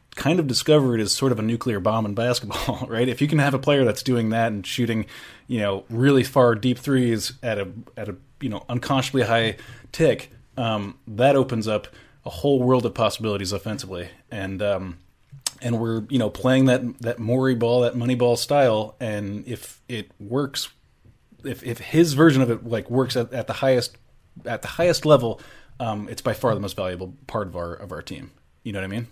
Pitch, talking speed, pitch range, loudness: 120 Hz, 210 wpm, 110-130 Hz, -22 LUFS